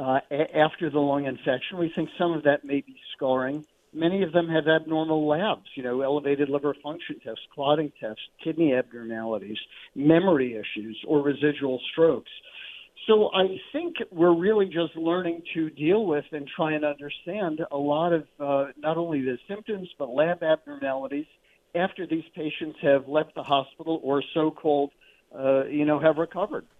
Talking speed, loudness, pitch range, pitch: 170 wpm, -26 LUFS, 140-170 Hz, 155 Hz